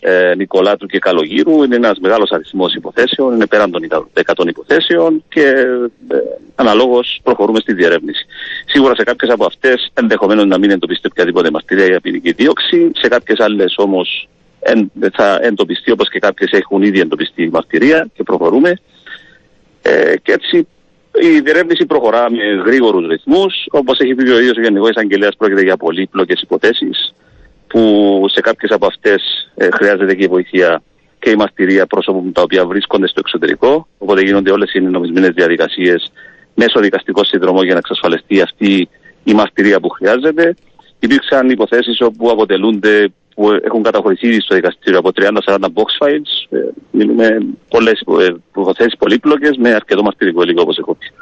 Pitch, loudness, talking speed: 125 Hz, -12 LUFS, 155 wpm